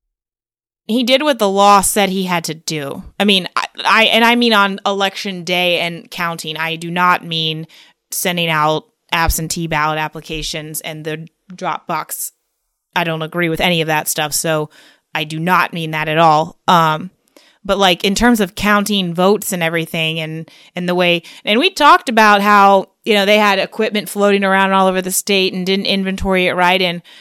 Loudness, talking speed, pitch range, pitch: -14 LUFS, 190 wpm, 160-200 Hz, 180 Hz